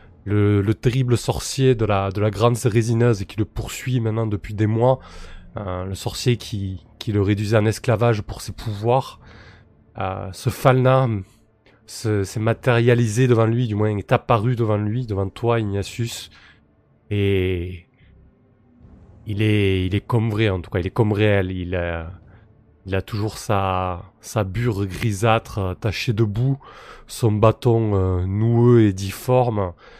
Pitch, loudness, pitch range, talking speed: 110 Hz, -21 LUFS, 95-115 Hz, 160 wpm